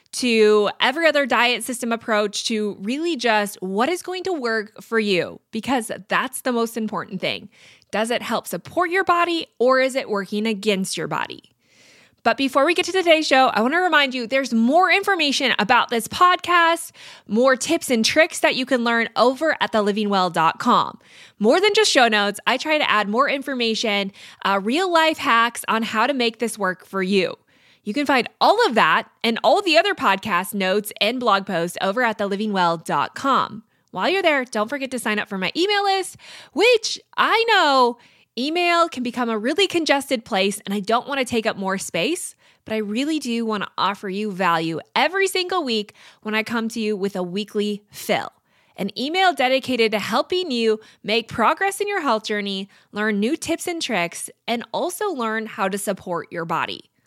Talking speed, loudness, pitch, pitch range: 190 wpm, -20 LUFS, 235 Hz, 210-305 Hz